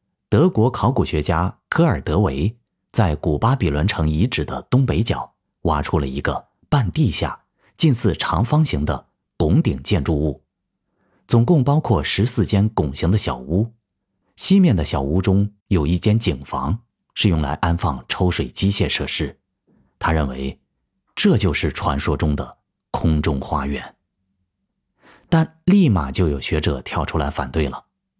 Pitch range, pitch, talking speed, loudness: 75-105 Hz, 95 Hz, 215 characters per minute, -20 LUFS